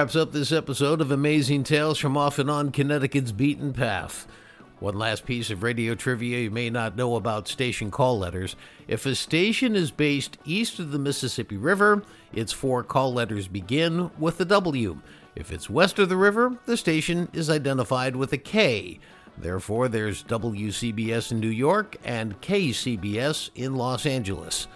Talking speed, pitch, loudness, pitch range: 170 wpm, 130 Hz, -25 LUFS, 115-155 Hz